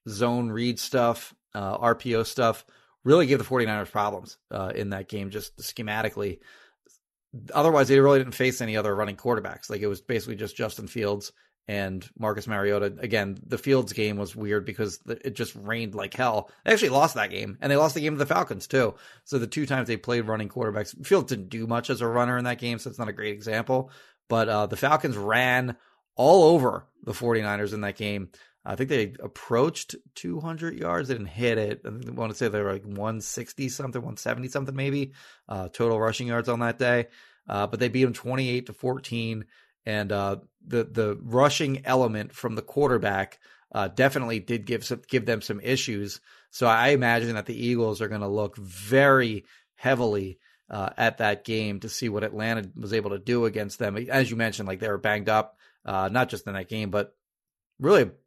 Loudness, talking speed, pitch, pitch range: -26 LUFS, 200 wpm, 115 Hz, 105-125 Hz